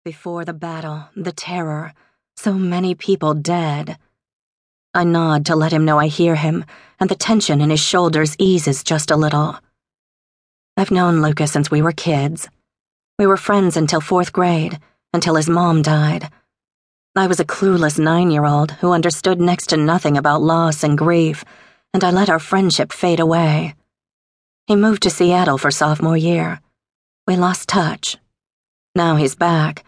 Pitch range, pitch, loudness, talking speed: 155-180 Hz, 165 Hz, -16 LUFS, 165 wpm